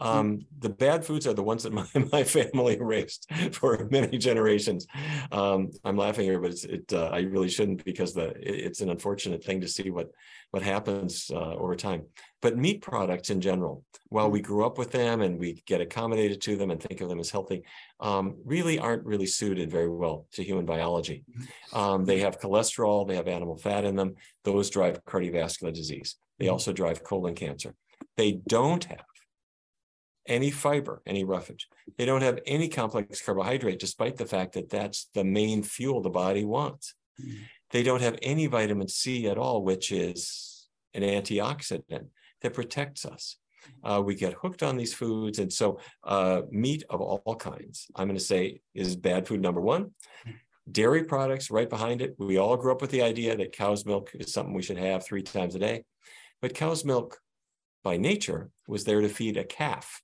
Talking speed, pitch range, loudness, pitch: 190 wpm, 95-125 Hz, -29 LUFS, 105 Hz